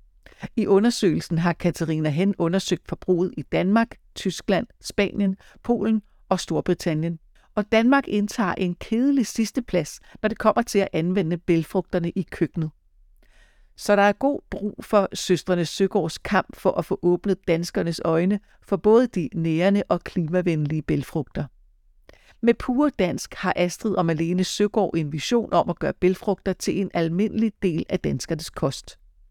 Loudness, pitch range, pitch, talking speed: -23 LUFS, 170-210 Hz, 185 Hz, 150 wpm